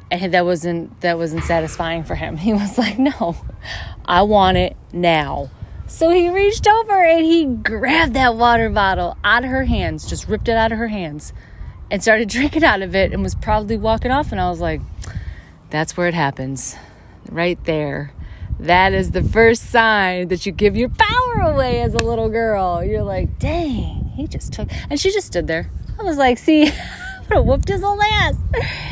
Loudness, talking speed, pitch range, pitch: -17 LUFS, 195 wpm, 165-250 Hz, 200 Hz